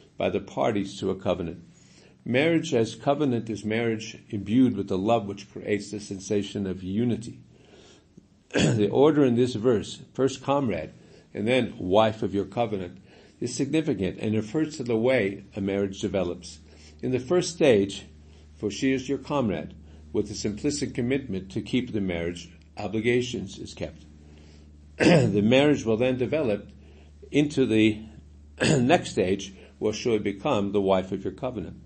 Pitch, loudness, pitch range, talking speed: 105 Hz, -26 LUFS, 95-125 Hz, 155 wpm